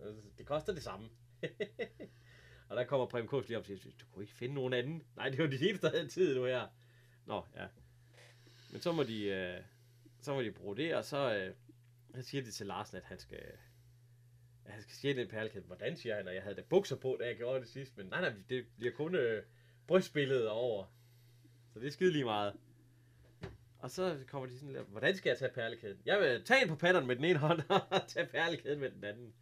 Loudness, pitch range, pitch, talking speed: -37 LUFS, 120-140 Hz, 120 Hz, 220 wpm